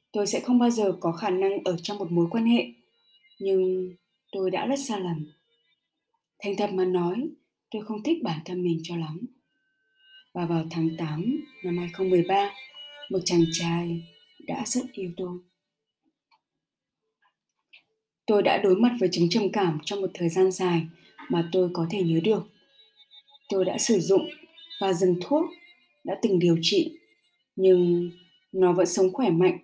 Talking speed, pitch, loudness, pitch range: 165 wpm, 190 Hz, -25 LUFS, 175-260 Hz